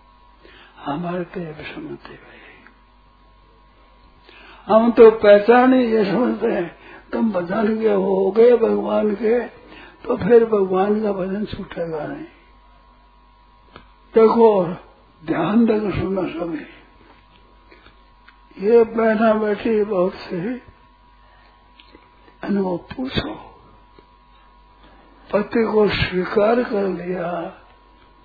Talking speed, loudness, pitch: 85 wpm, -18 LUFS, 190 Hz